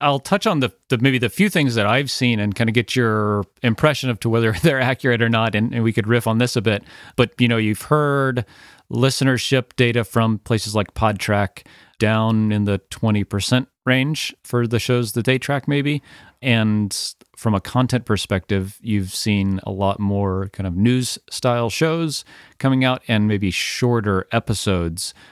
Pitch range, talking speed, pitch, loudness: 105-130 Hz, 185 wpm, 115 Hz, -20 LUFS